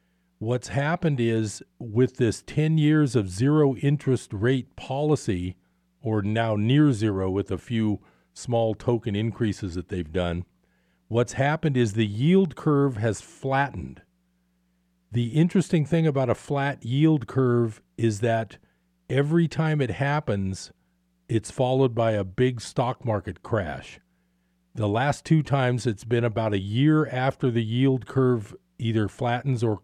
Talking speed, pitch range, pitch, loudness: 145 wpm, 100-135 Hz, 115 Hz, -25 LUFS